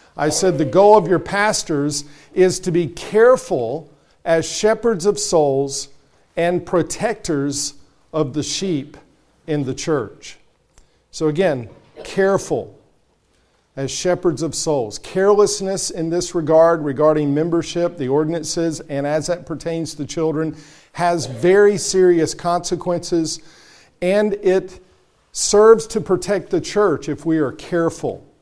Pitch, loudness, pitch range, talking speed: 165 Hz, -18 LUFS, 150-185 Hz, 125 wpm